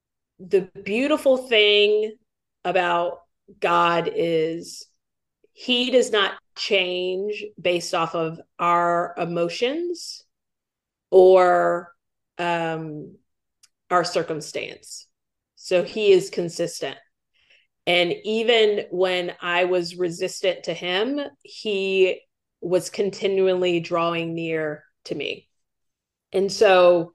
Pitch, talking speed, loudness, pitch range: 180 Hz, 90 wpm, -22 LUFS, 175-210 Hz